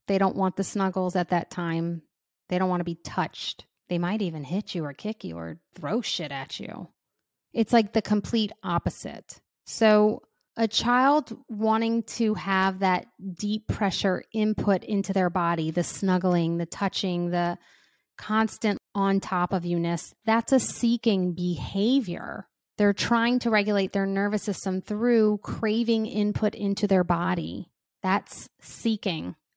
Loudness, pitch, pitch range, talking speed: -26 LUFS, 195 Hz, 180-220 Hz, 150 wpm